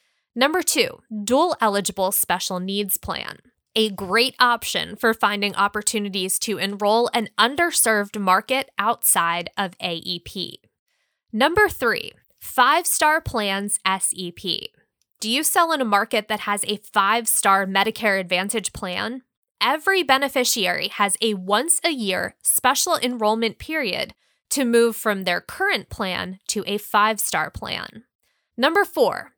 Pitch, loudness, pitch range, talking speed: 220 Hz, -21 LUFS, 200-260 Hz, 130 wpm